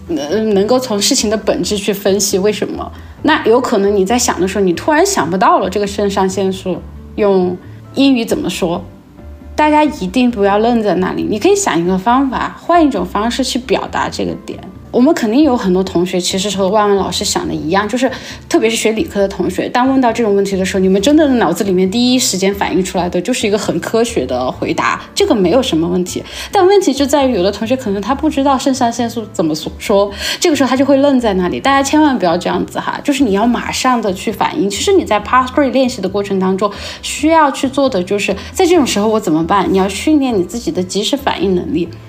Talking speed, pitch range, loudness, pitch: 360 characters per minute, 195-270 Hz, -13 LUFS, 220 Hz